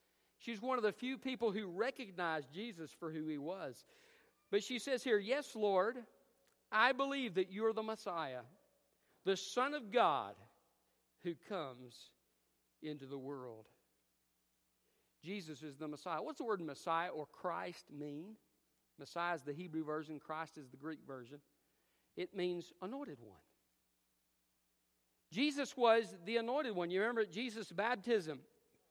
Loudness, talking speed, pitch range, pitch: -40 LUFS, 145 wpm, 140-225 Hz, 175 Hz